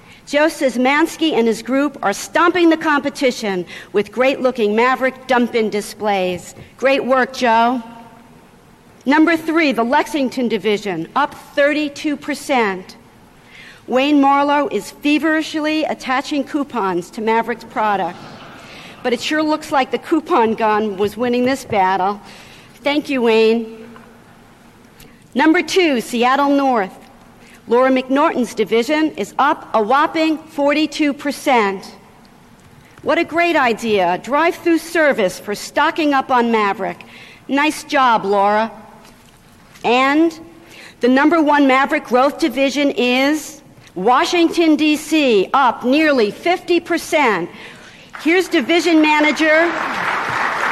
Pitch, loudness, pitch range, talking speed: 270 Hz, -16 LUFS, 225-305 Hz, 110 wpm